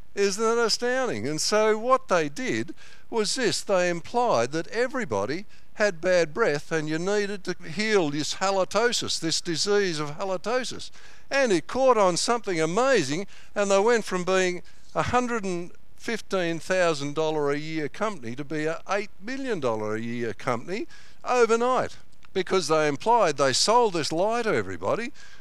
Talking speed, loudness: 160 wpm, -25 LUFS